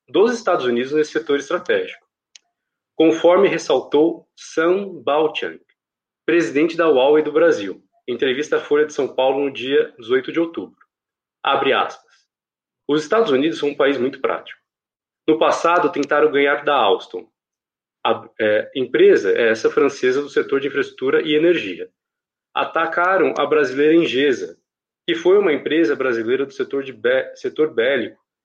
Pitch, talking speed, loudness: 385 Hz, 145 wpm, -18 LUFS